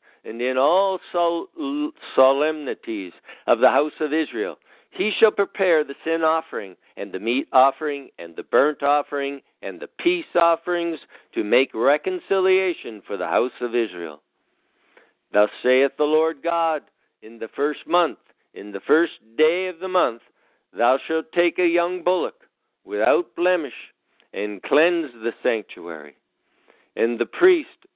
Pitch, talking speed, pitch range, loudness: 160 Hz, 140 wpm, 135-185 Hz, -22 LUFS